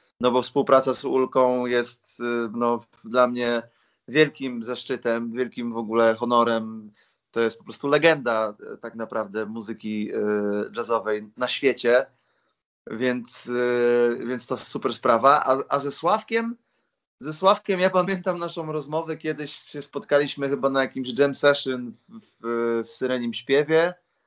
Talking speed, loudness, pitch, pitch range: 140 wpm, -24 LUFS, 125 Hz, 115-145 Hz